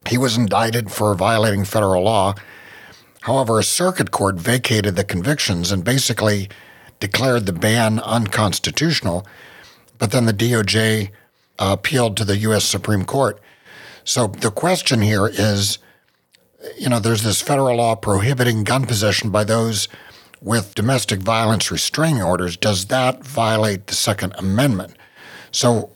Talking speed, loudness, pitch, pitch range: 135 wpm, -18 LUFS, 110 Hz, 100-120 Hz